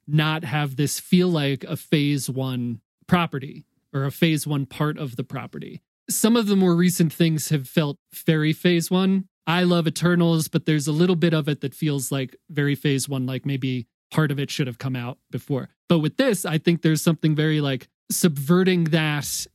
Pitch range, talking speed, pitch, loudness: 140-175 Hz, 200 wpm, 155 Hz, -22 LUFS